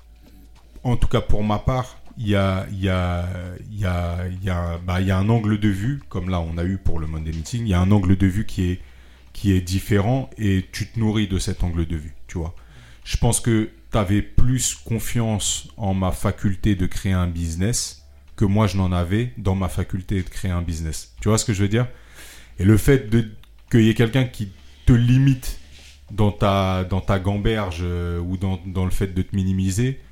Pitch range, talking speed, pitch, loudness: 90-110 Hz, 220 wpm, 95 Hz, -22 LUFS